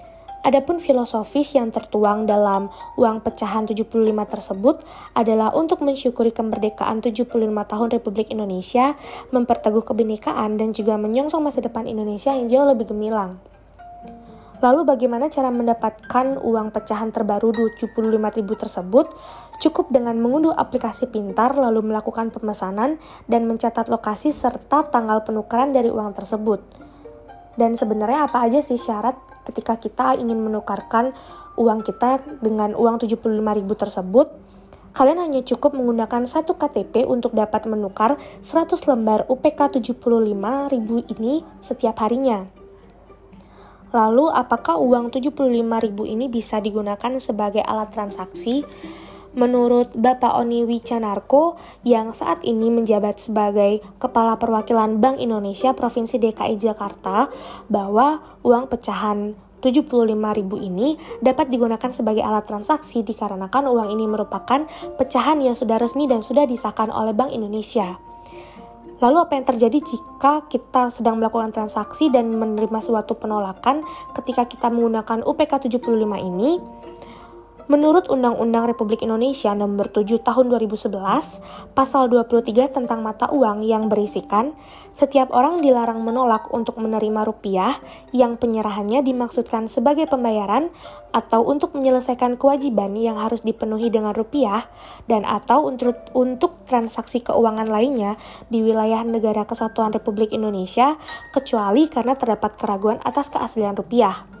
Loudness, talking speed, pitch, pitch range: -20 LUFS, 125 wpm, 230 Hz, 215-260 Hz